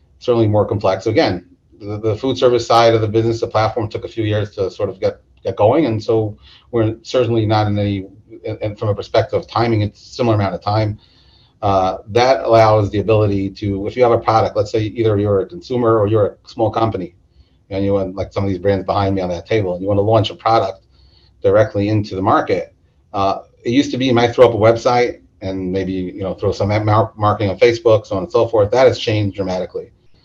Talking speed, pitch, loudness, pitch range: 230 wpm, 105 Hz, -16 LUFS, 95-115 Hz